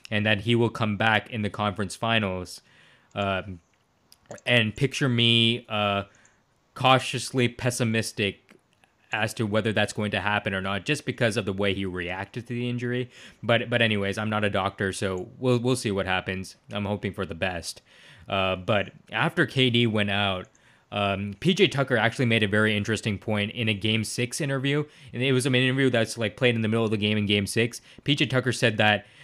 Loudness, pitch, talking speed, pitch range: -25 LUFS, 110 Hz, 195 wpm, 100-120 Hz